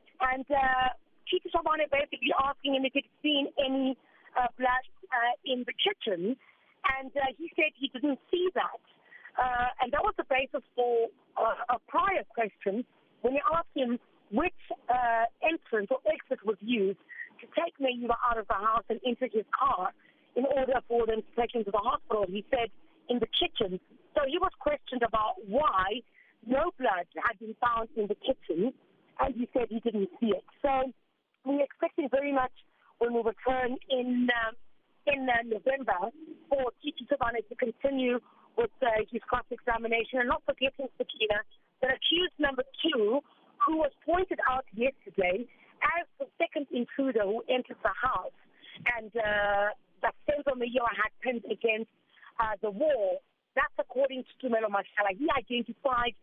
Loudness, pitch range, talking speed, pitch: -30 LUFS, 230-290 Hz, 165 wpm, 255 Hz